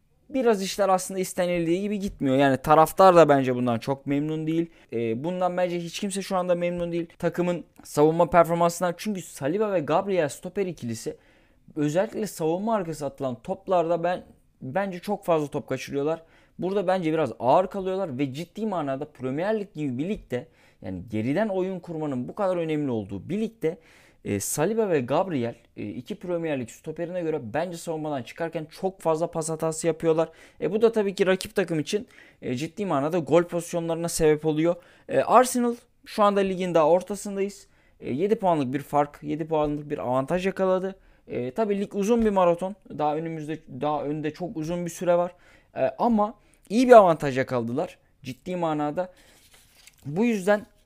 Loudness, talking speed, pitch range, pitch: -25 LUFS, 160 wpm, 150-190 Hz, 170 Hz